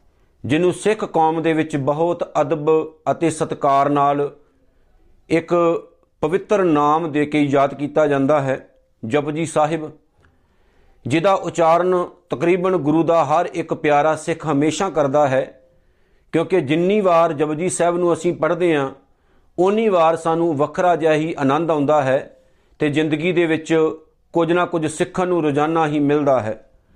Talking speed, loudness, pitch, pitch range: 140 wpm, -18 LUFS, 155 Hz, 145-170 Hz